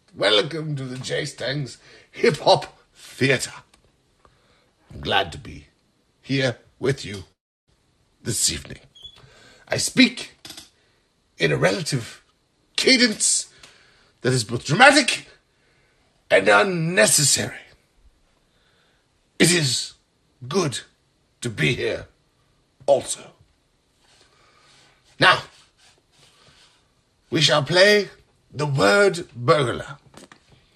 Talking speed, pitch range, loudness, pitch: 85 wpm, 125-175 Hz, -20 LUFS, 145 Hz